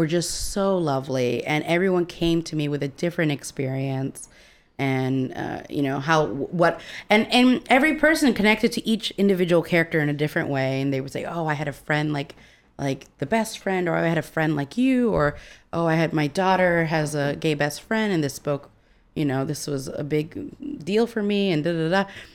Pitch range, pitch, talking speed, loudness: 145-190 Hz, 160 Hz, 215 wpm, -23 LUFS